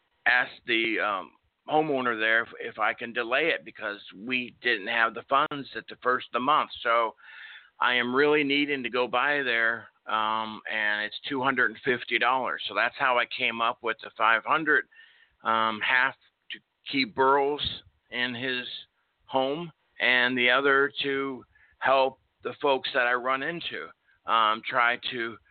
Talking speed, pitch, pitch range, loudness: 160 wpm, 125 Hz, 115-140 Hz, -26 LUFS